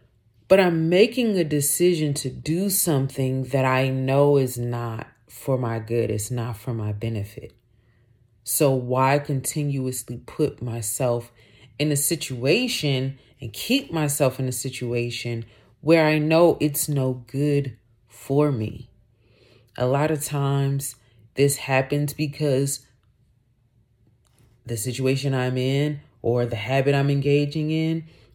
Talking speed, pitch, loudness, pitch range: 125 wpm, 130 Hz, -23 LUFS, 120-145 Hz